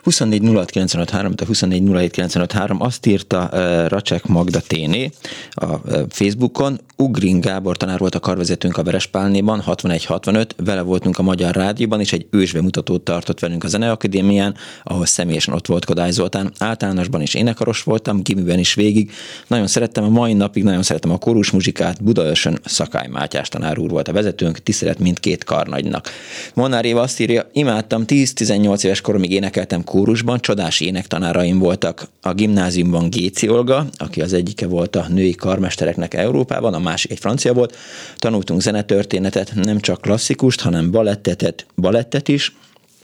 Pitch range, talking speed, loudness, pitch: 90-110 Hz, 150 wpm, -17 LUFS, 100 Hz